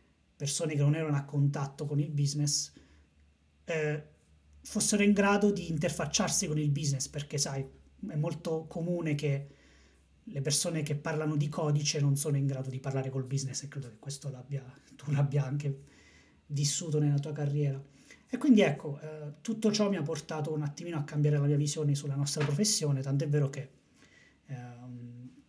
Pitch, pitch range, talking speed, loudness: 145 Hz, 135-155 Hz, 170 wpm, -31 LUFS